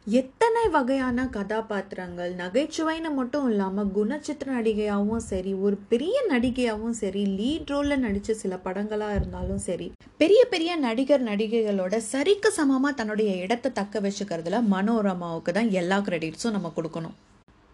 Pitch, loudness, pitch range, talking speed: 220 Hz, -26 LUFS, 195-270 Hz, 120 wpm